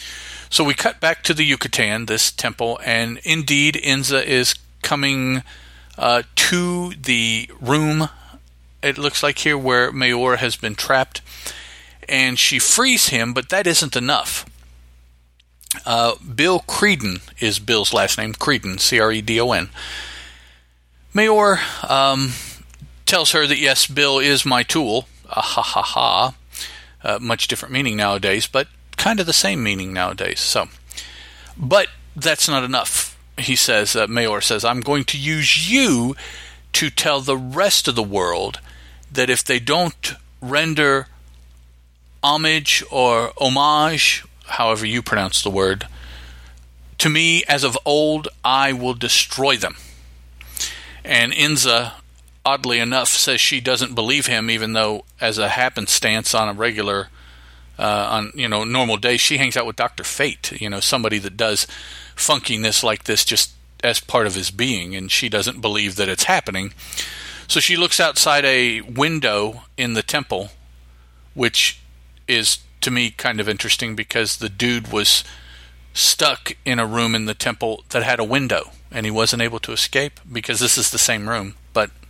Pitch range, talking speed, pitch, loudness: 90-135 Hz, 155 wpm, 115 Hz, -17 LUFS